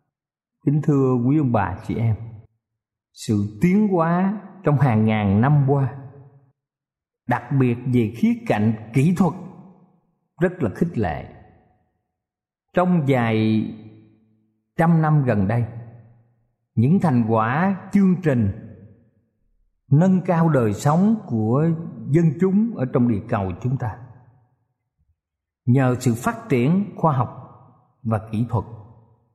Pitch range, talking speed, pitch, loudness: 110-155 Hz, 120 wpm, 125 Hz, -20 LUFS